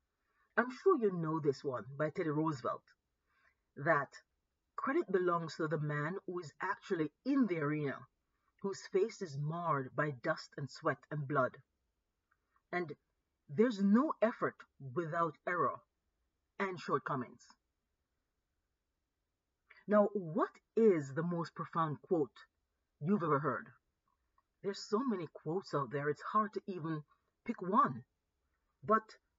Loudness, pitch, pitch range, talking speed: -36 LUFS, 160 Hz, 140-200 Hz, 125 wpm